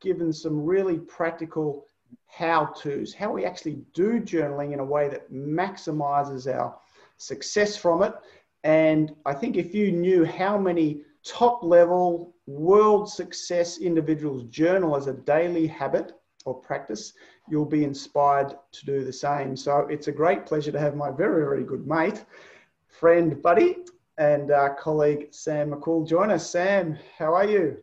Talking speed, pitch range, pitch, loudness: 155 wpm, 145-175 Hz, 155 Hz, -24 LUFS